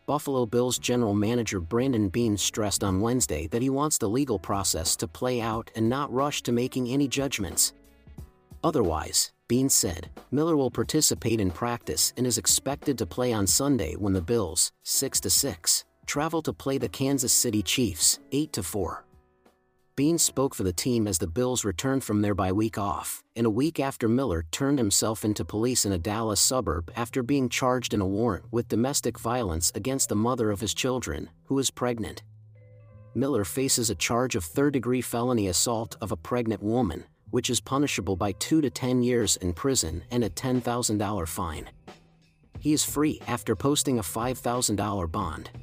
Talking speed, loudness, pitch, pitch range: 175 wpm, -26 LUFS, 115 Hz, 100-130 Hz